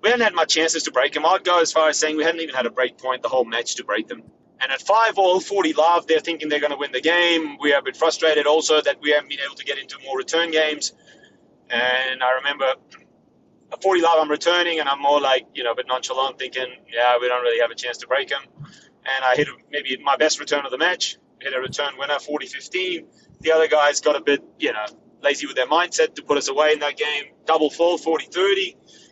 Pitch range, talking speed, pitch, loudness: 135-165 Hz, 250 wpm, 150 Hz, -20 LUFS